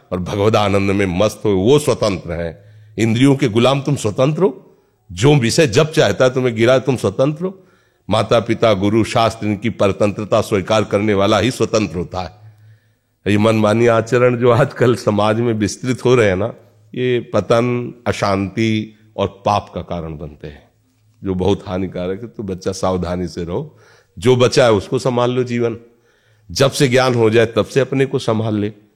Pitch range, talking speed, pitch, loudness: 100-125 Hz, 180 wpm, 110 Hz, -16 LUFS